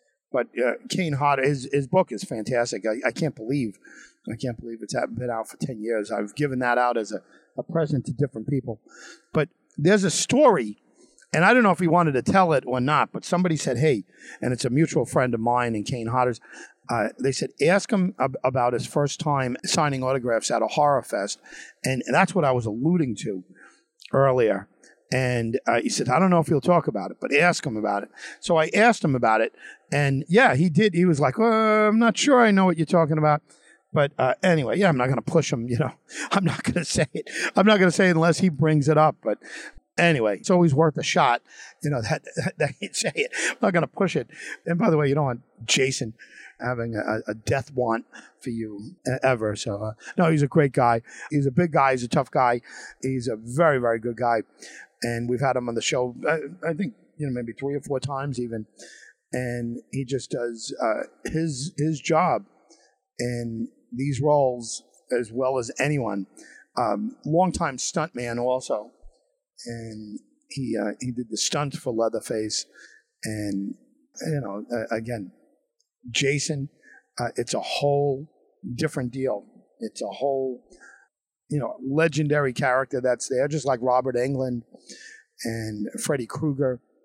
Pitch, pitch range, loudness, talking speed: 135 Hz, 120-165 Hz, -24 LUFS, 200 wpm